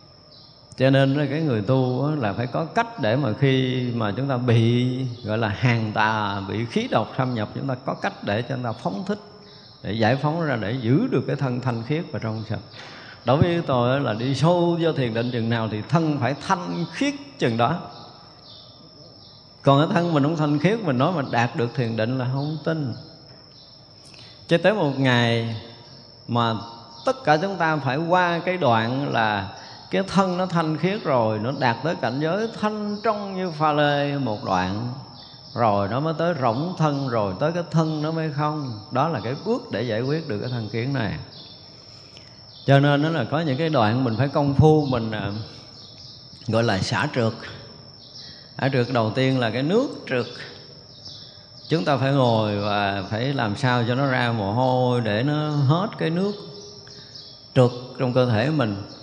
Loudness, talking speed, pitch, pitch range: -23 LUFS, 195 wpm, 130 Hz, 115-150 Hz